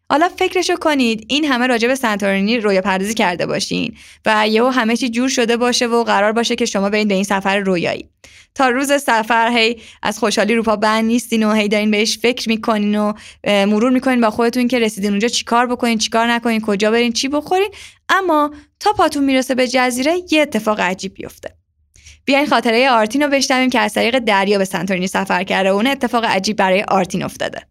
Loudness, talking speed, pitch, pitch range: -16 LUFS, 195 wpm, 230 Hz, 210-255 Hz